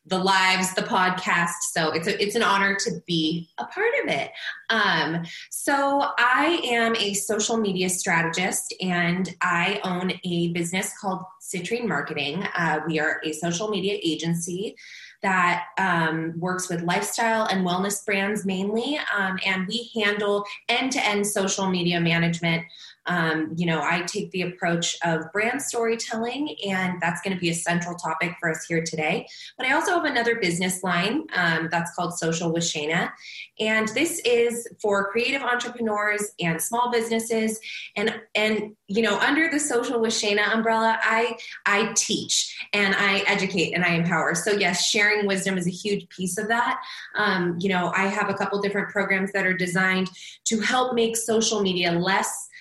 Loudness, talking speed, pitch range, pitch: -23 LUFS, 170 wpm, 175-225 Hz, 195 Hz